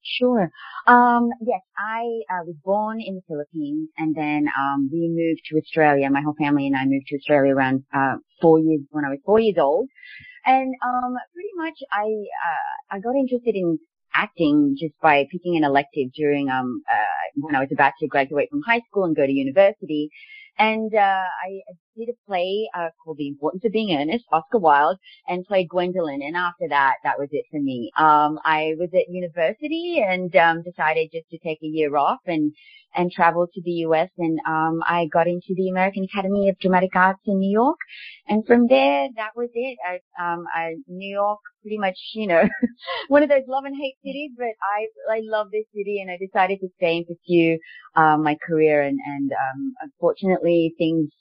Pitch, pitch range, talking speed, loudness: 185 Hz, 160-235 Hz, 200 wpm, -21 LUFS